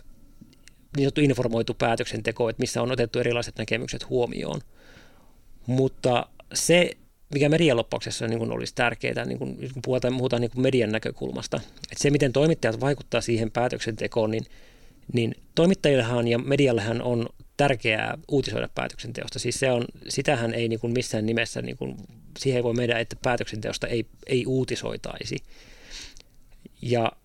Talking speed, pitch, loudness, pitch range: 140 wpm, 120 Hz, -26 LUFS, 115-130 Hz